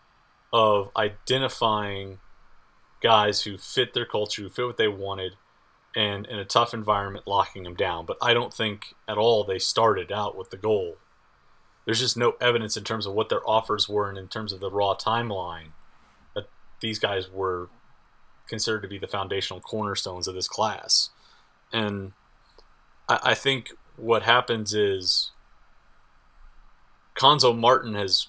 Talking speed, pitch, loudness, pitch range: 155 wpm, 105 Hz, -25 LUFS, 95-115 Hz